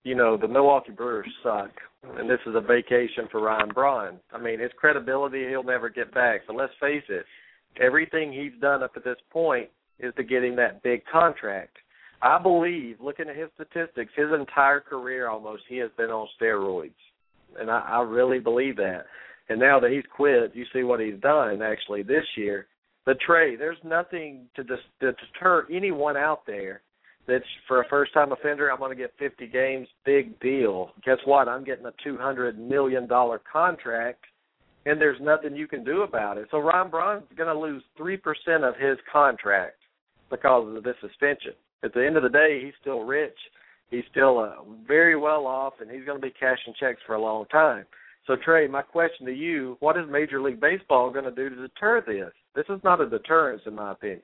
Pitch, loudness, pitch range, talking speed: 135 Hz, -24 LUFS, 125-155 Hz, 200 wpm